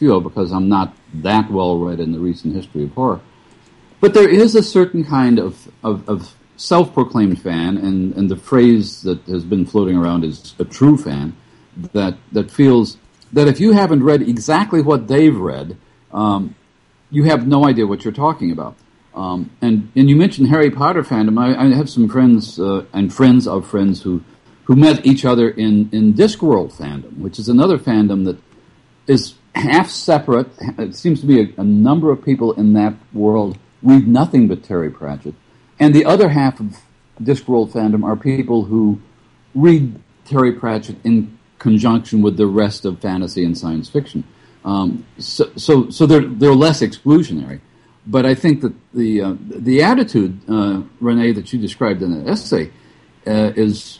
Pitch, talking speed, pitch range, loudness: 115 Hz, 175 wpm, 100-140 Hz, -15 LUFS